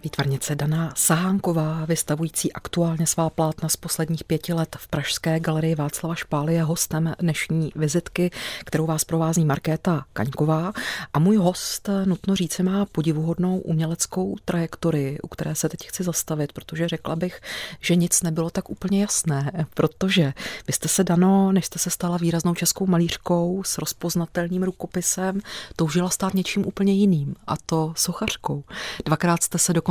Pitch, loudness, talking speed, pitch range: 165 Hz, -23 LUFS, 155 wpm, 160-180 Hz